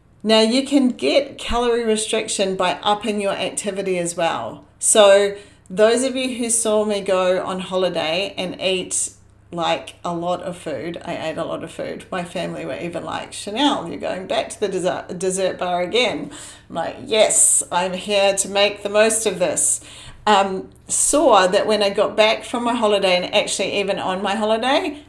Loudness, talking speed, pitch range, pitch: -19 LUFS, 180 wpm, 185-220 Hz, 200 Hz